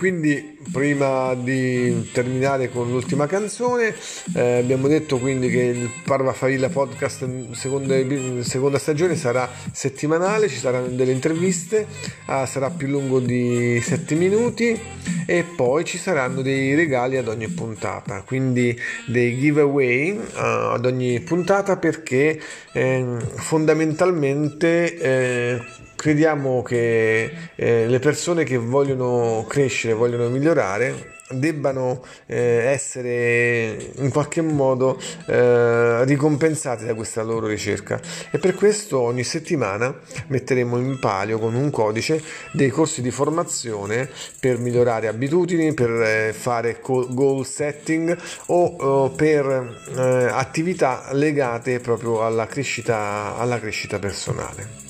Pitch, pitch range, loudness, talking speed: 130 Hz, 120-155 Hz, -21 LUFS, 115 wpm